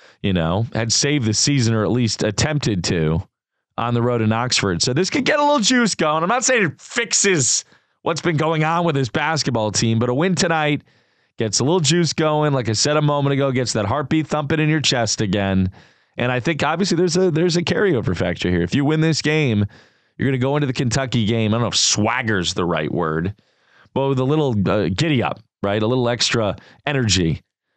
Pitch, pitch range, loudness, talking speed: 130 Hz, 110-155 Hz, -19 LUFS, 225 wpm